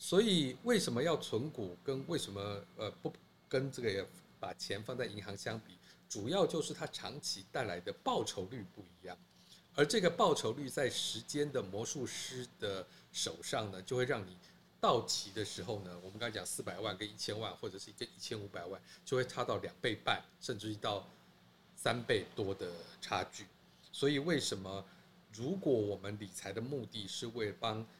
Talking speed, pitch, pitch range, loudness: 265 characters per minute, 110 Hz, 100-130 Hz, -38 LUFS